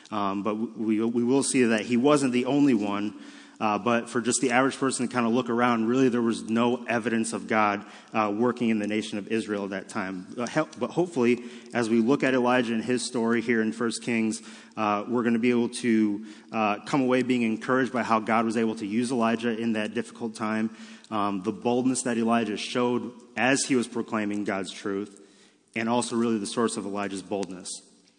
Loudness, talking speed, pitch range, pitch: -26 LUFS, 215 wpm, 110-120 Hz, 115 Hz